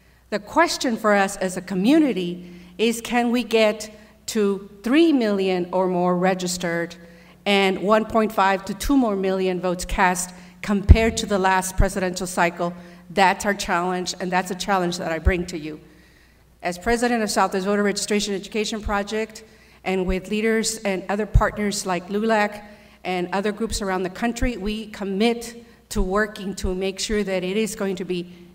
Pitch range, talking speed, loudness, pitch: 185-215 Hz, 165 wpm, -22 LUFS, 195 Hz